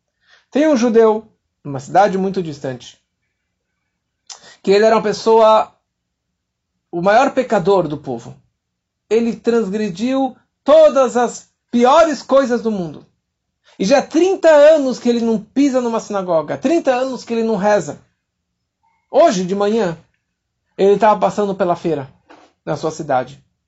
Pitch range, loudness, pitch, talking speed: 155-250 Hz, -15 LUFS, 210 Hz, 135 wpm